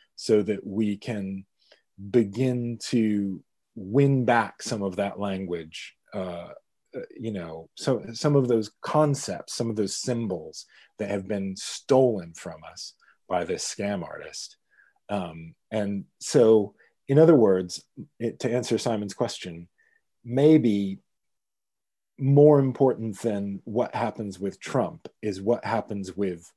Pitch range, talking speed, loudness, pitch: 100-125 Hz, 130 wpm, -25 LUFS, 110 Hz